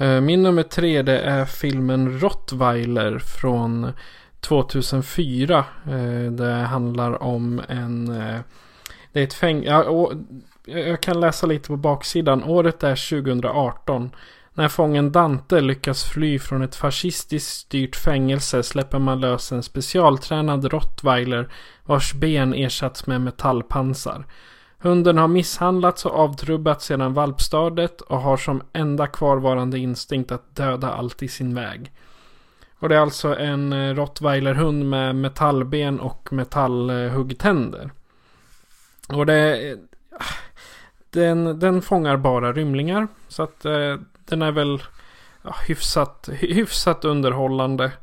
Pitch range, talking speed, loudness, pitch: 130-155 Hz, 110 wpm, -21 LUFS, 140 Hz